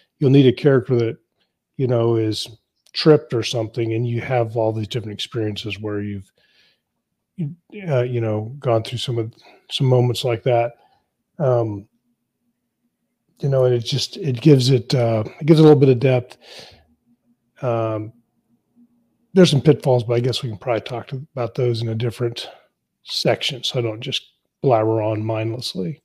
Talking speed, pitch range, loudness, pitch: 175 wpm, 115-135 Hz, -19 LUFS, 120 Hz